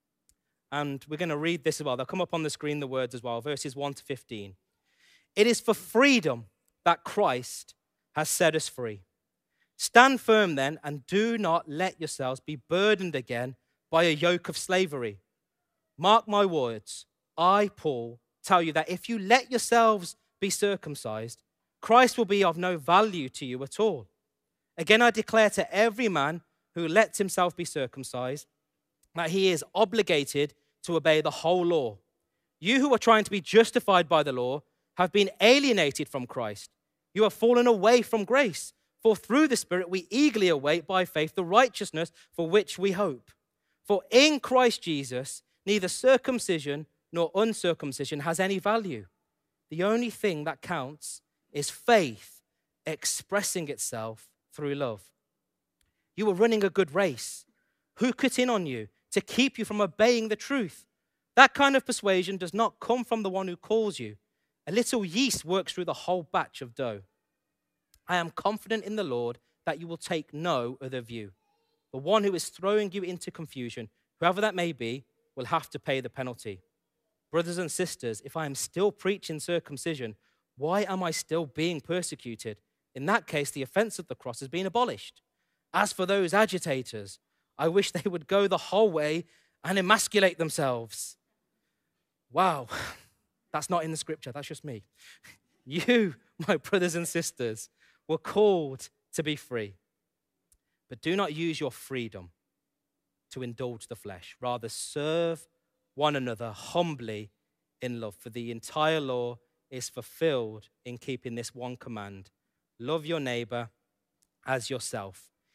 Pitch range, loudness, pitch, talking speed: 130-205 Hz, -27 LUFS, 165 Hz, 165 wpm